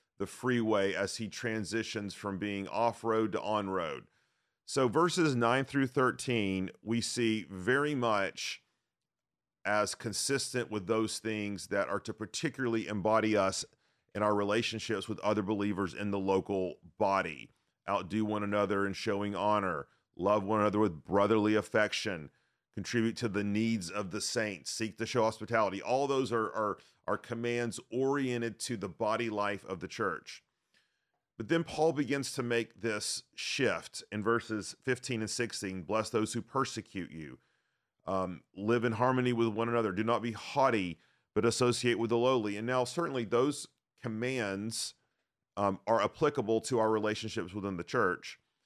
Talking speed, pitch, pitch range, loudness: 155 wpm, 110 Hz, 105-120 Hz, -33 LUFS